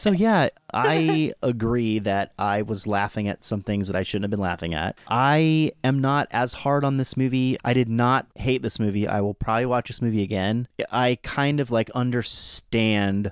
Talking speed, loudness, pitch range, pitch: 200 wpm, -23 LUFS, 100-130 Hz, 115 Hz